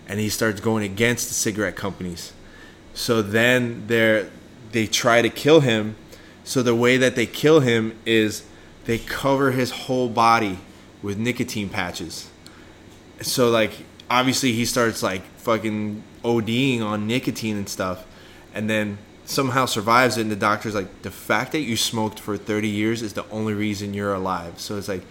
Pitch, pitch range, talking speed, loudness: 110 Hz, 100-120 Hz, 165 wpm, -22 LUFS